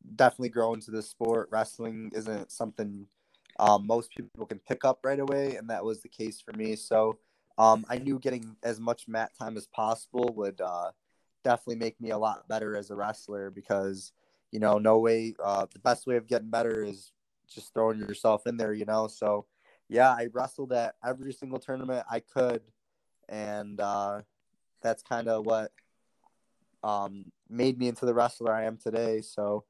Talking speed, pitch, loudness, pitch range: 185 wpm, 110 Hz, -30 LUFS, 105-120 Hz